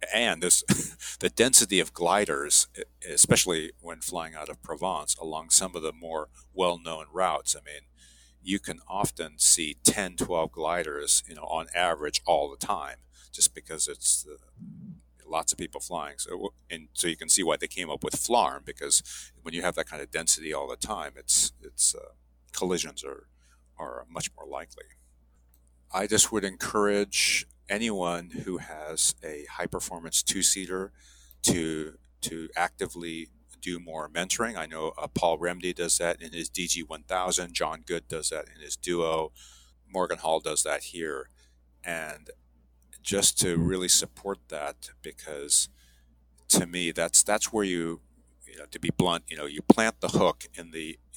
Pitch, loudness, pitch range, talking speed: 80 Hz, -26 LUFS, 60-85 Hz, 165 wpm